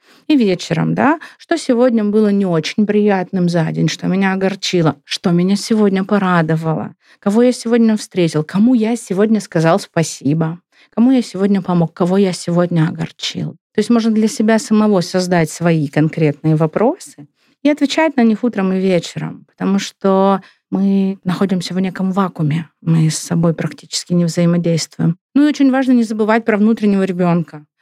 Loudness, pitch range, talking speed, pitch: -15 LUFS, 170-220 Hz, 160 wpm, 190 Hz